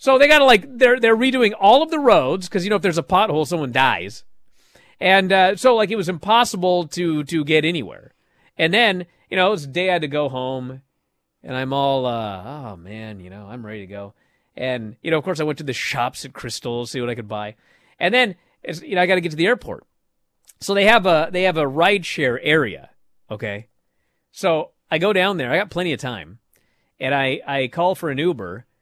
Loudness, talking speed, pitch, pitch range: -18 LUFS, 240 wpm, 160 Hz, 130-190 Hz